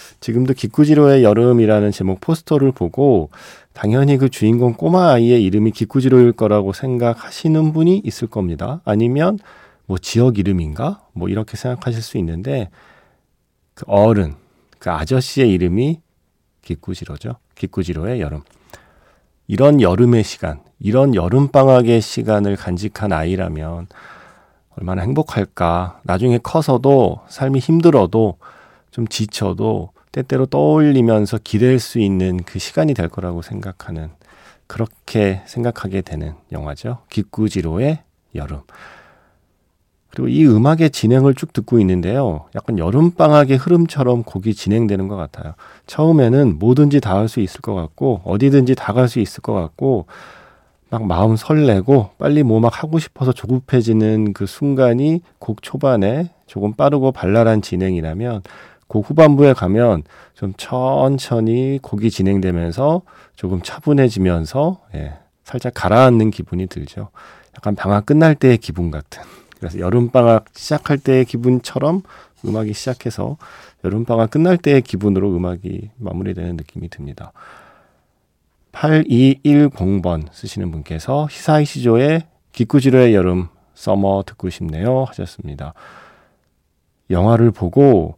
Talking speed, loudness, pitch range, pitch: 295 characters per minute, -16 LUFS, 95-130 Hz, 110 Hz